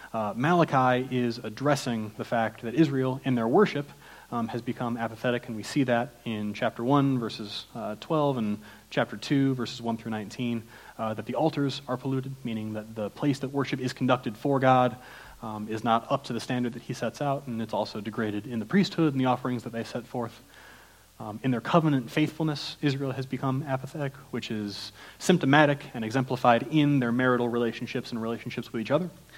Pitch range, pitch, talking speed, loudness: 115-140 Hz, 125 Hz, 195 wpm, -28 LUFS